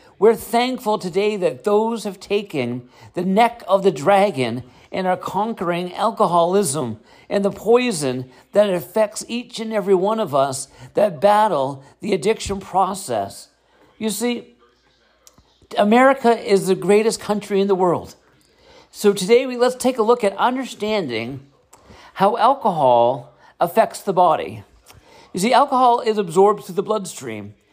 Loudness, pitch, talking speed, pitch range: -19 LUFS, 200 Hz, 140 wpm, 175-220 Hz